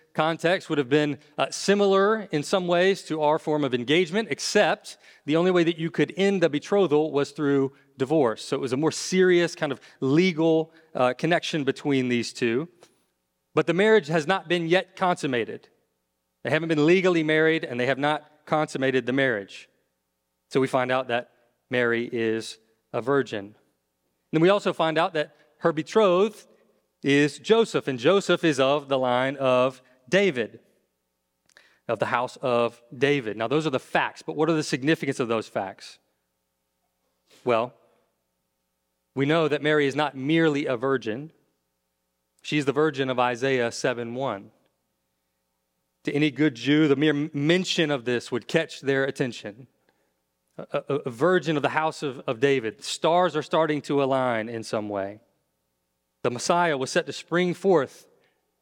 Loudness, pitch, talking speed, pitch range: -24 LUFS, 145 Hz, 165 wpm, 120-165 Hz